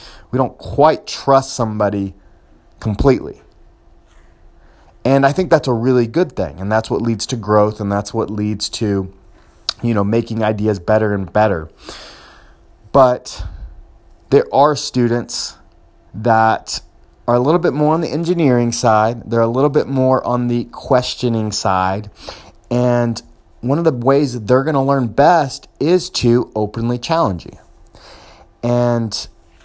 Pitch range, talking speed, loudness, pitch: 100-130 Hz, 145 wpm, -16 LUFS, 115 Hz